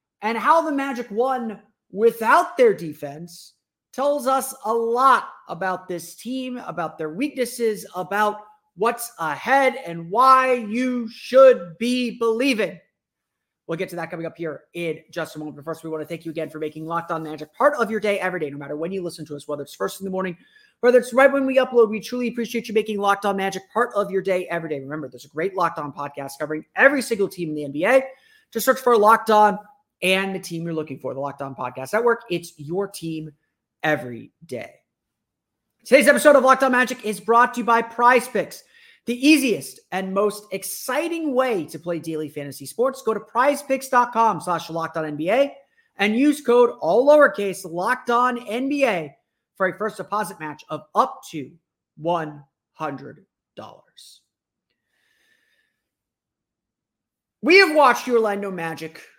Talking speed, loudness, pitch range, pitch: 175 wpm, -21 LUFS, 165-250 Hz, 205 Hz